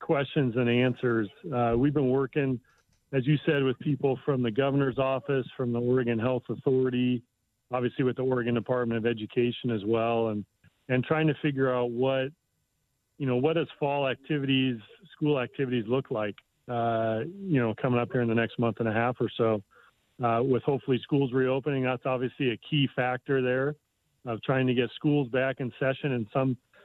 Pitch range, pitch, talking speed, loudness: 120-135 Hz, 130 Hz, 185 wpm, -28 LUFS